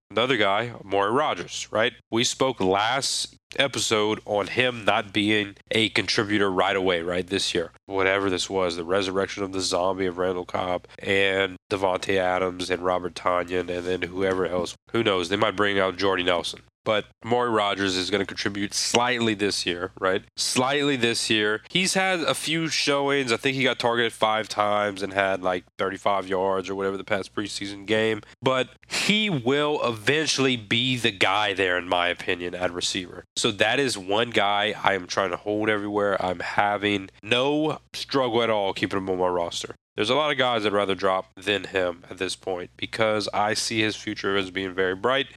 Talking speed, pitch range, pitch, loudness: 190 wpm, 95-120 Hz, 105 Hz, -24 LUFS